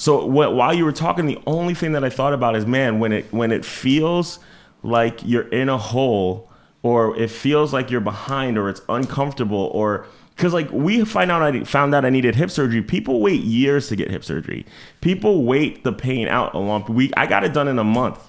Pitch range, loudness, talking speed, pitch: 115-145 Hz, -19 LUFS, 225 wpm, 130 Hz